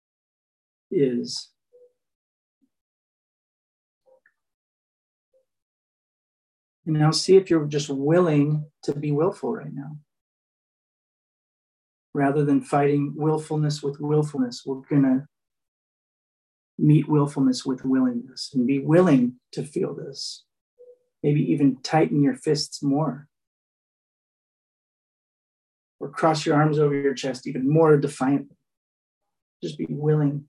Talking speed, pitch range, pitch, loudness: 100 wpm, 140-155 Hz, 150 Hz, -23 LUFS